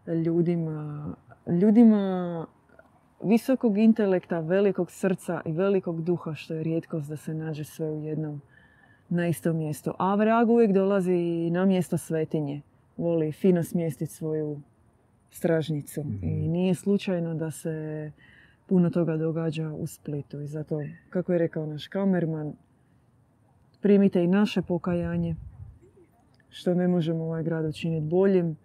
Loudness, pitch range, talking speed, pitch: -26 LUFS, 155-180 Hz, 130 wpm, 165 Hz